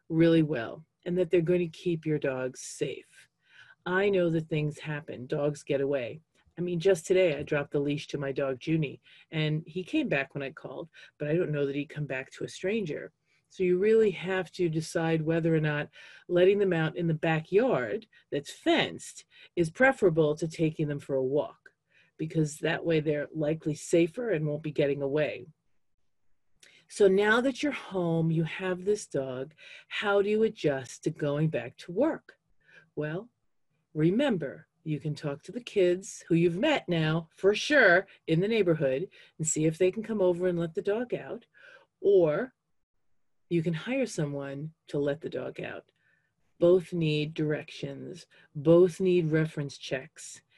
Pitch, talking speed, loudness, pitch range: 165 Hz, 175 wpm, -29 LUFS, 150-185 Hz